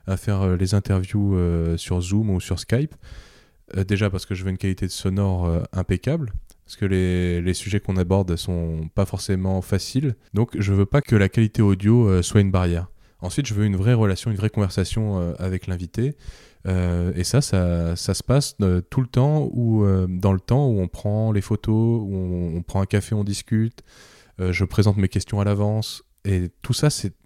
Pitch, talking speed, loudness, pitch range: 100 Hz, 195 wpm, -22 LUFS, 90-110 Hz